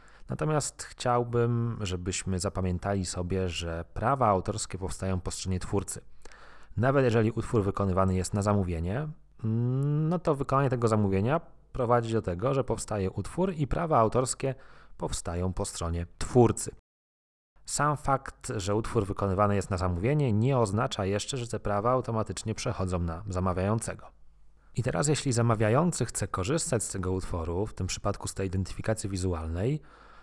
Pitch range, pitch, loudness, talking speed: 95-125 Hz, 105 Hz, -29 LUFS, 140 wpm